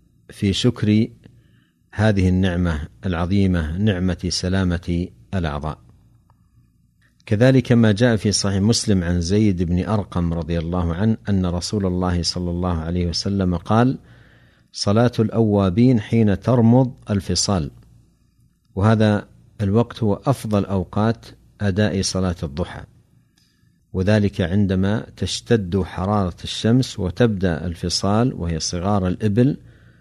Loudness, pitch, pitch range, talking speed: -20 LUFS, 100 Hz, 90-110 Hz, 105 wpm